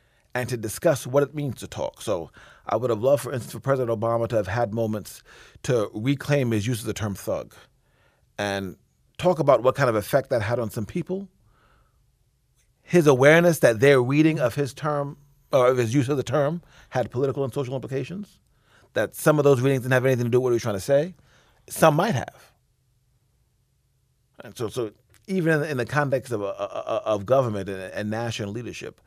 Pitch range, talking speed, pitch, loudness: 115-140 Hz, 195 wpm, 125 Hz, -24 LUFS